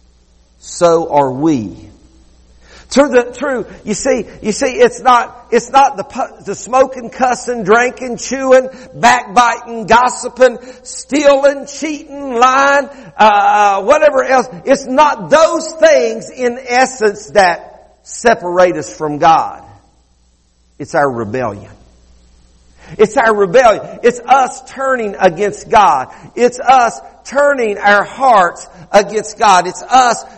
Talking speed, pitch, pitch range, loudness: 115 wpm, 235 Hz, 180-260 Hz, -12 LUFS